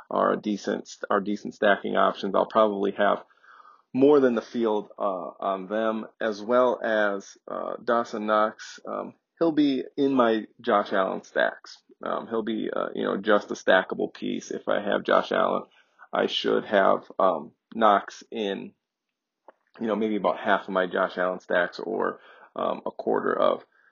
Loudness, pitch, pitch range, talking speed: -25 LUFS, 110 Hz, 105-120 Hz, 170 wpm